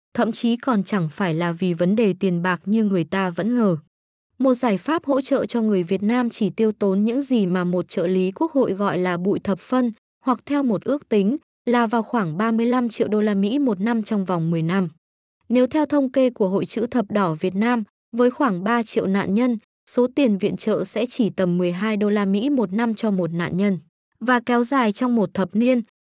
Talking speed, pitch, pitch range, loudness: 235 wpm, 215 Hz, 190-245 Hz, -21 LUFS